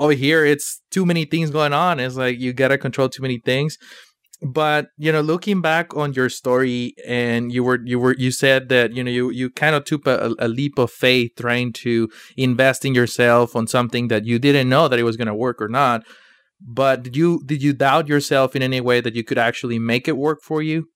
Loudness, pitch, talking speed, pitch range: -19 LUFS, 130 Hz, 230 wpm, 120-150 Hz